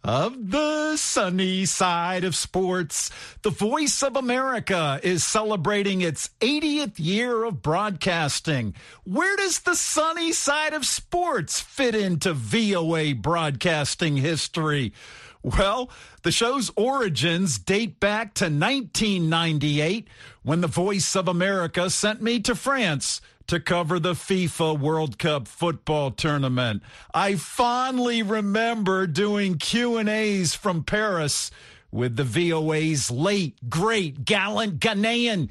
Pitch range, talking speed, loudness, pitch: 155-225 Hz, 120 wpm, -23 LUFS, 185 Hz